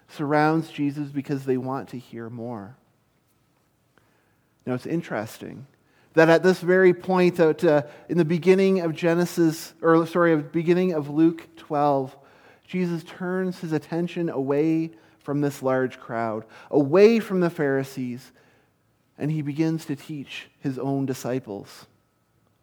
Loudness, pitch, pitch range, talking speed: -23 LUFS, 145 Hz, 130-165 Hz, 135 wpm